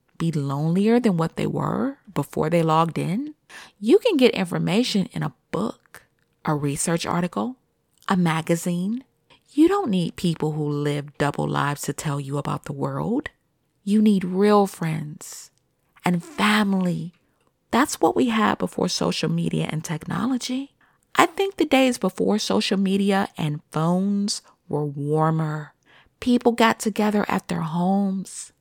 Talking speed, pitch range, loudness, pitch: 145 wpm, 155-215 Hz, -23 LUFS, 185 Hz